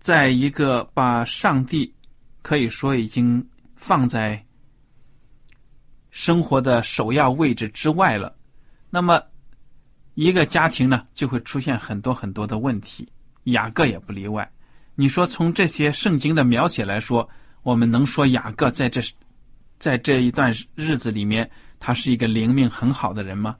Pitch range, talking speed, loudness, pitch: 115-140 Hz, 220 characters per minute, -21 LUFS, 130 Hz